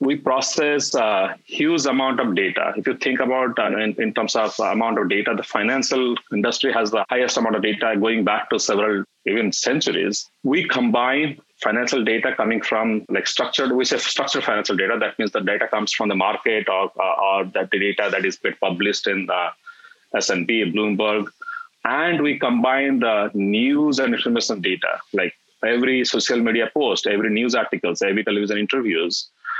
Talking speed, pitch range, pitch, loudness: 175 wpm, 110-155 Hz, 130 Hz, -20 LUFS